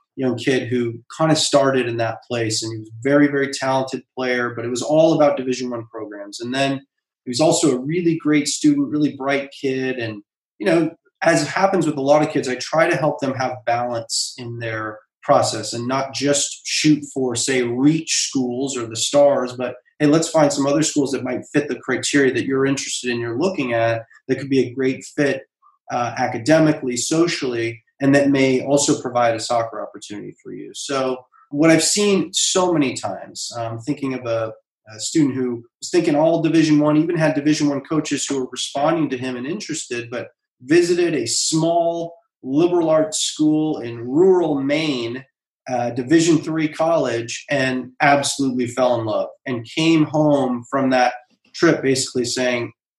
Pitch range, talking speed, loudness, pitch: 125-155 Hz, 185 wpm, -19 LUFS, 135 Hz